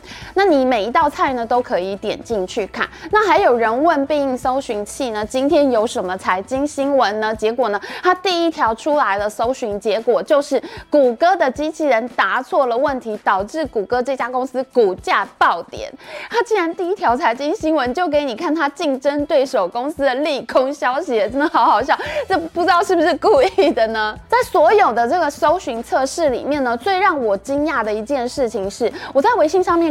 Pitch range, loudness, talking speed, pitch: 240-325 Hz, -17 LUFS, 290 characters per minute, 280 Hz